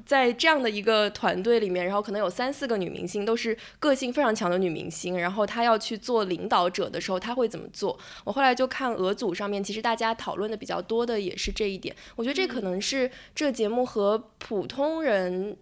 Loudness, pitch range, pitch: -27 LUFS, 200-250 Hz, 220 Hz